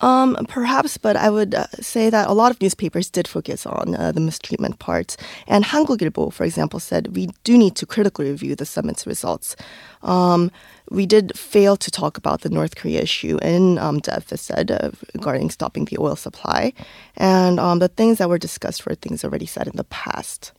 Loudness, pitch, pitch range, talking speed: -20 LUFS, 200 Hz, 175-225 Hz, 190 wpm